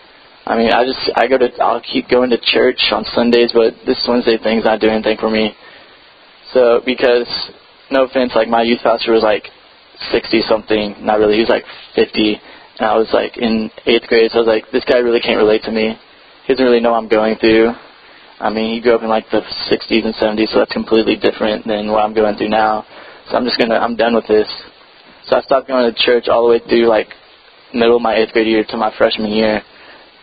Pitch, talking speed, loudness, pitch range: 115 Hz, 235 wpm, -14 LUFS, 110-120 Hz